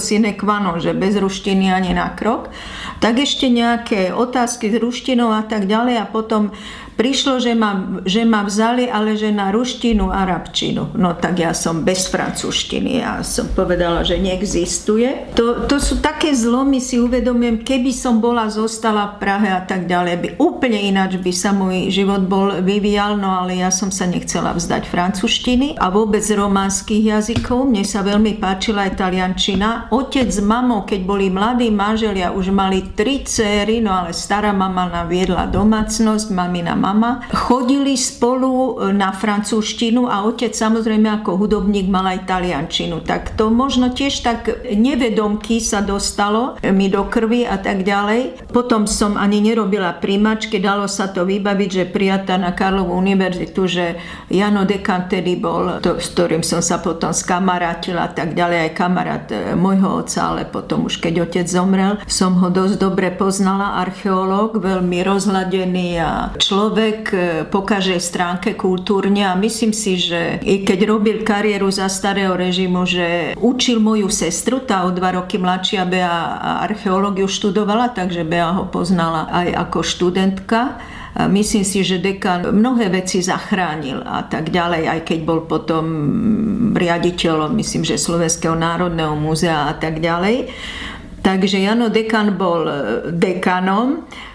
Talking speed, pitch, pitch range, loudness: 155 wpm, 200 Hz, 185-220 Hz, -17 LUFS